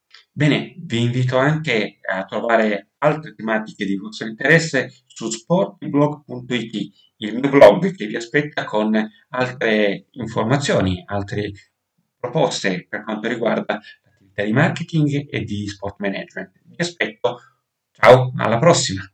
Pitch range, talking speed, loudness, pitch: 105-145 Hz, 120 wpm, -19 LUFS, 115 Hz